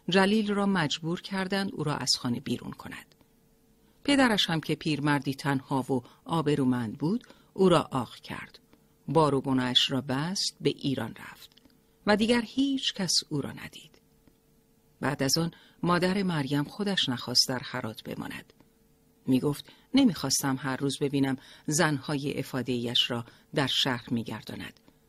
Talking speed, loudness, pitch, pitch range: 145 wpm, -28 LUFS, 145 Hz, 130-185 Hz